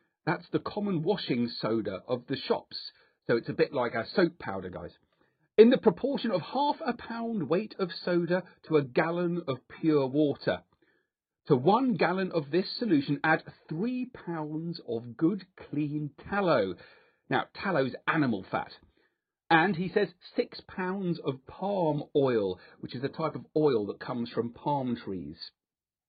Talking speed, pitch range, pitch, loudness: 160 wpm, 140-190 Hz, 160 Hz, -30 LUFS